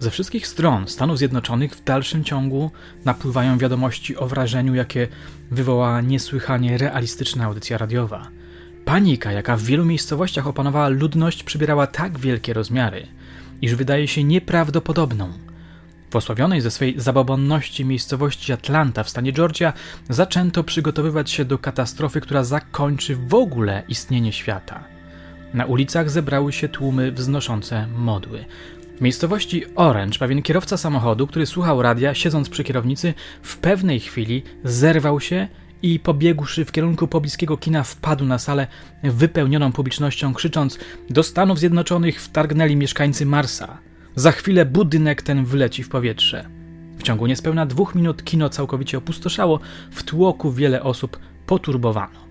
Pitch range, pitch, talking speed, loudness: 125-160 Hz, 140 Hz, 130 wpm, -20 LUFS